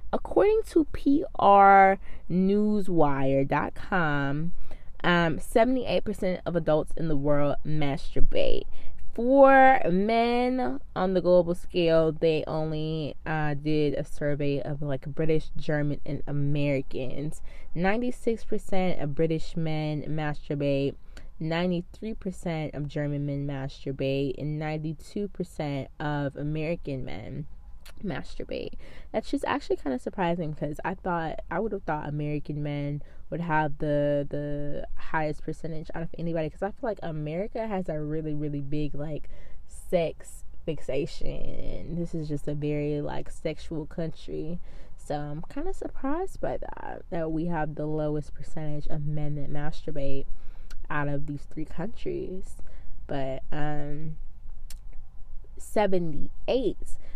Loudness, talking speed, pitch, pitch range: -28 LUFS, 120 wpm, 155 Hz, 145-180 Hz